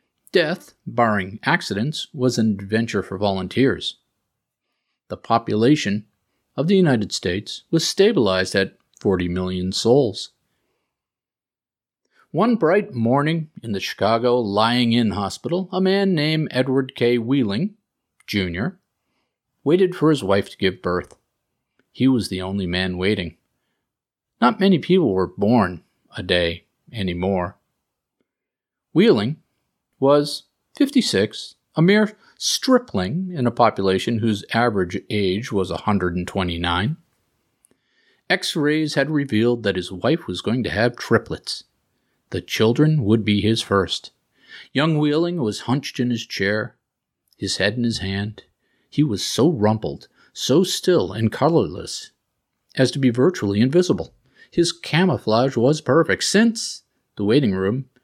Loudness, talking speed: -20 LUFS, 125 wpm